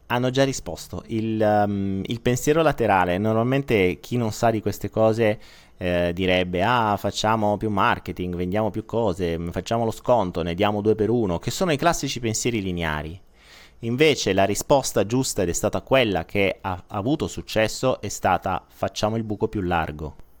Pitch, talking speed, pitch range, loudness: 105 Hz, 170 wpm, 90-115 Hz, -23 LUFS